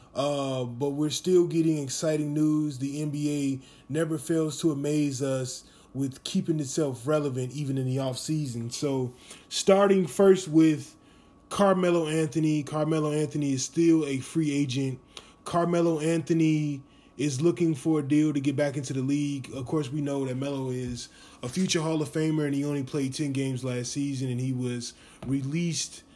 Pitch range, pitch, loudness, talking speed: 135-160 Hz, 145 Hz, -27 LUFS, 165 wpm